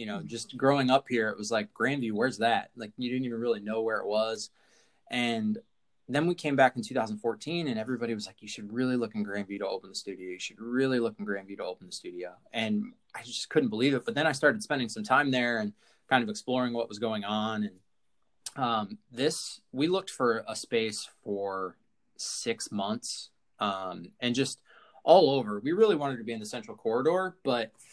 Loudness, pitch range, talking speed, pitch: -30 LUFS, 105-135 Hz, 215 wpm, 115 Hz